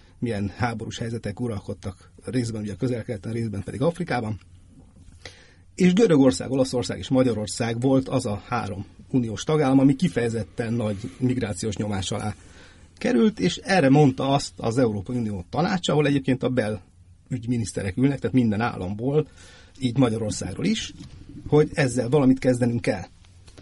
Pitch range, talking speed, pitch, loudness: 100-130 Hz, 135 wpm, 115 Hz, -24 LUFS